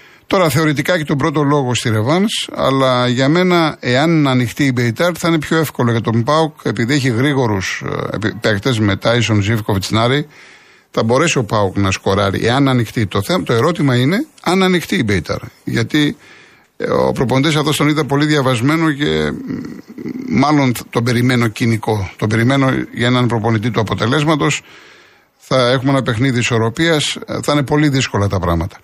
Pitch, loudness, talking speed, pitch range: 130 Hz, -15 LUFS, 165 wpm, 115-150 Hz